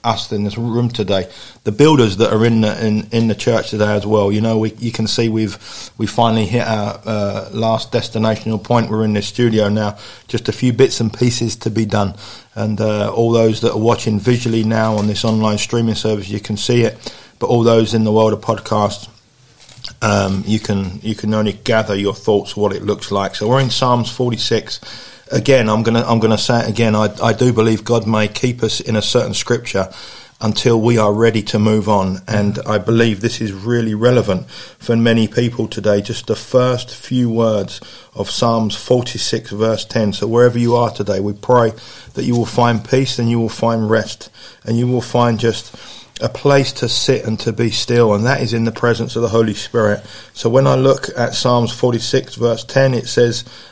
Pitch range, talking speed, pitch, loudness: 105-120 Hz, 215 wpm, 115 Hz, -16 LUFS